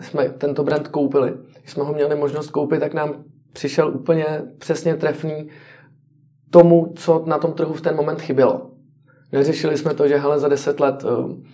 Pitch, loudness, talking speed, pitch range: 150 Hz, -19 LUFS, 170 wpm, 145-155 Hz